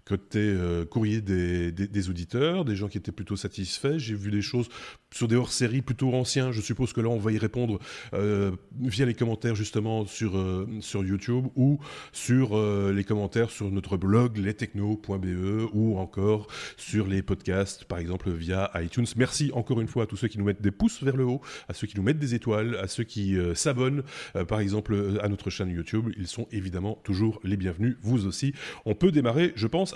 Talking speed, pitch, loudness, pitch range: 210 wpm, 105 Hz, -28 LUFS, 100-120 Hz